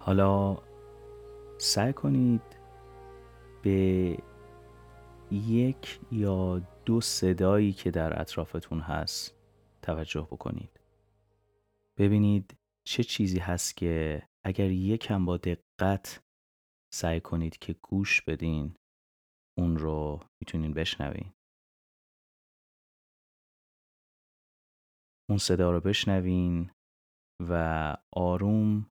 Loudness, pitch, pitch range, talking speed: -29 LUFS, 95 Hz, 80-105 Hz, 80 wpm